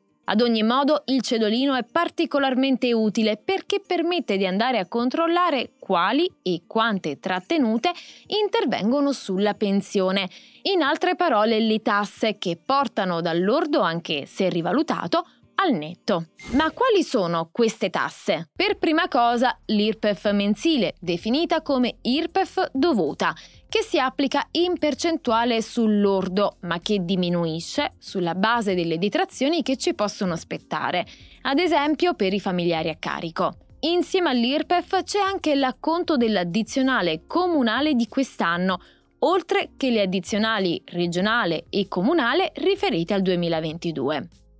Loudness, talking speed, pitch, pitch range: -23 LUFS, 120 wpm, 235 Hz, 195-315 Hz